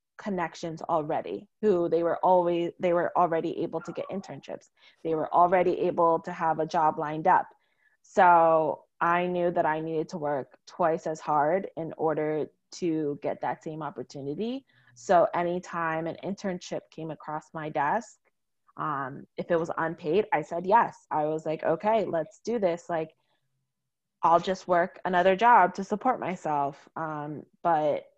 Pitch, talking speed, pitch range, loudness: 165 Hz, 160 wpm, 155-180 Hz, -27 LUFS